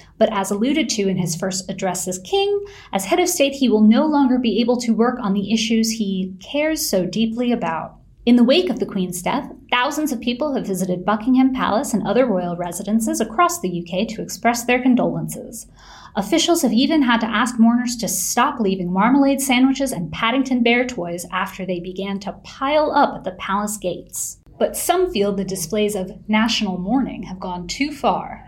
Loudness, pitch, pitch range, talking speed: -19 LUFS, 225 Hz, 195-260 Hz, 195 wpm